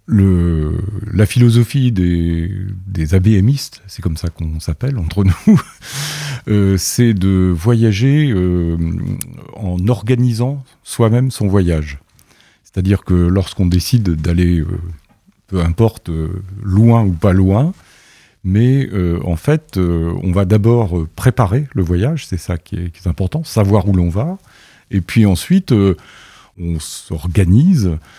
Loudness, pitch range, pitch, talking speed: -15 LUFS, 90-120 Hz, 95 Hz, 120 wpm